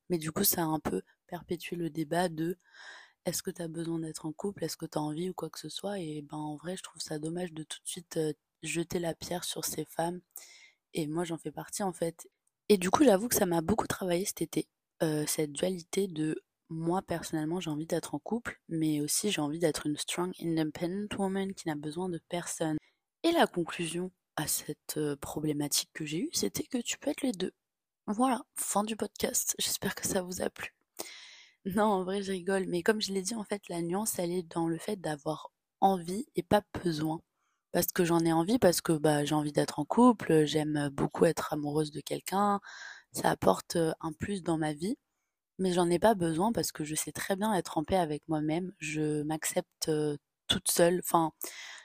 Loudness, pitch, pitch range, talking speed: -32 LUFS, 170 Hz, 155-195 Hz, 215 wpm